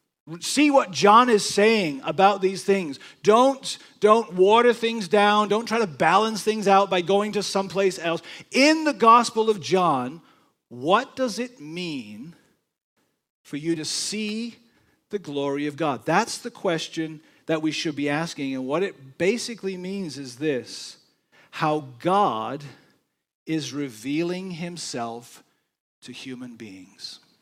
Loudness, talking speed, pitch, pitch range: -22 LUFS, 140 wpm, 185 Hz, 150-215 Hz